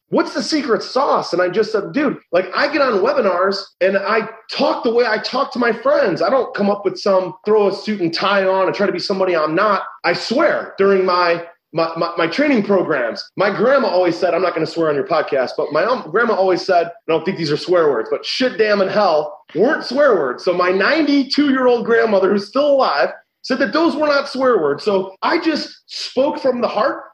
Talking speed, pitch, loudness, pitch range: 235 wpm, 205 Hz, -17 LUFS, 180-275 Hz